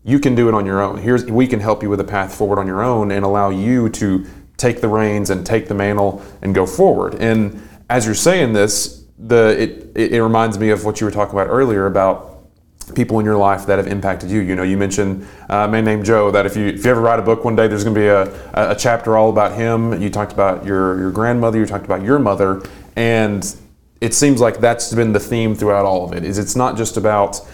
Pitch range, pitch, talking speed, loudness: 100-115 Hz, 105 Hz, 255 wpm, -16 LUFS